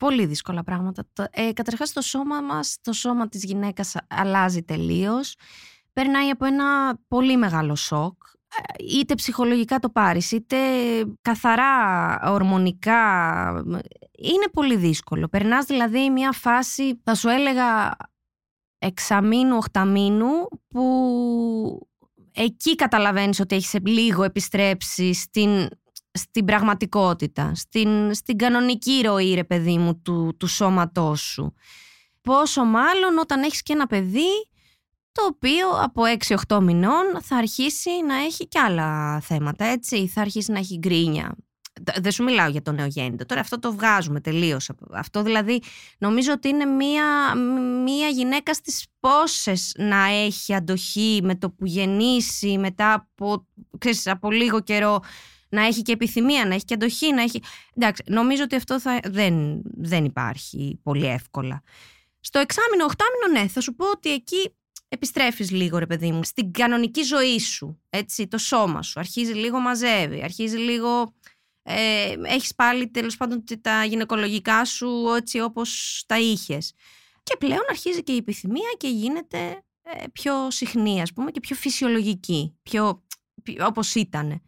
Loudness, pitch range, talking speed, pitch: -22 LUFS, 190-255 Hz, 140 wpm, 225 Hz